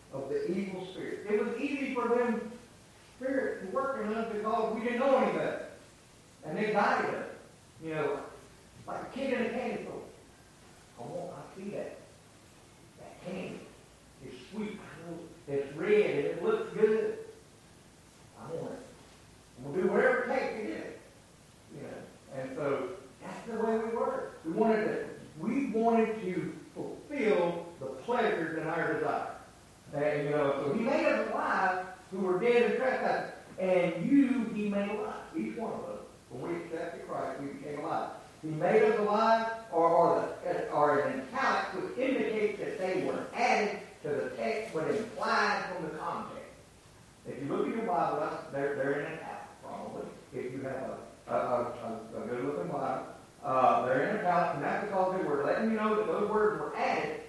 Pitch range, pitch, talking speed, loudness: 170-240 Hz, 210 Hz, 175 wpm, -32 LUFS